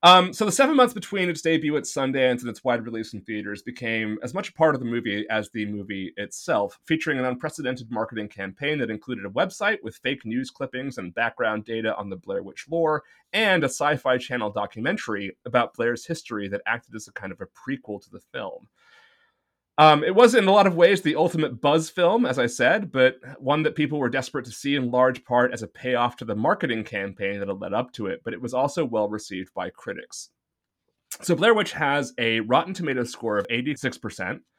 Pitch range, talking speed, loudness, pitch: 110-160 Hz, 220 wpm, -24 LUFS, 130 Hz